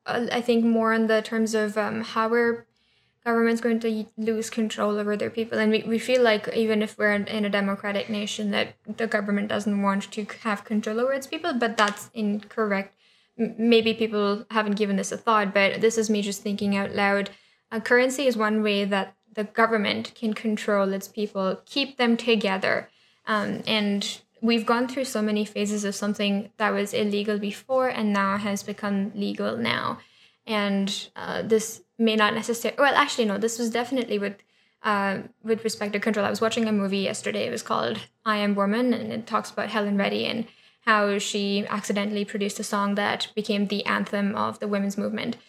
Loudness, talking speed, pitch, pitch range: -25 LUFS, 195 wpm, 215 Hz, 205-225 Hz